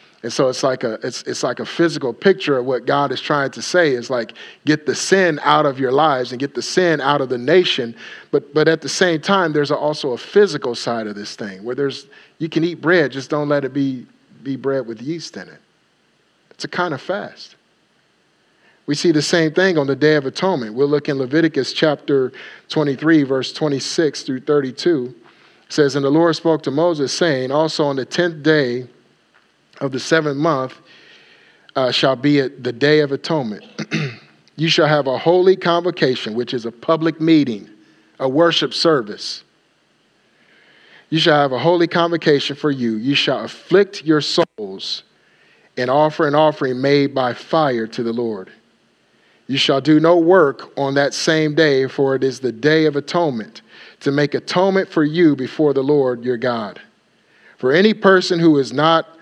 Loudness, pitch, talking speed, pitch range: -17 LUFS, 150 Hz, 190 wpm, 135-165 Hz